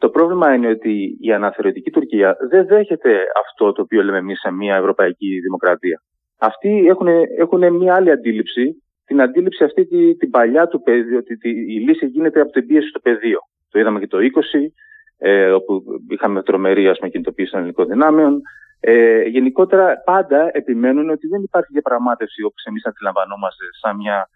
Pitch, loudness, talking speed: 165 Hz, -16 LUFS, 170 wpm